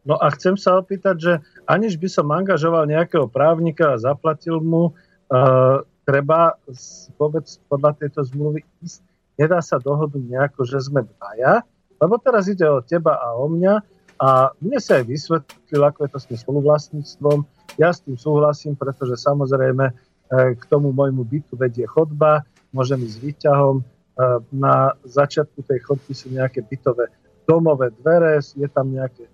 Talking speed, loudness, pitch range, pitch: 160 wpm, -19 LUFS, 135-165 Hz, 145 Hz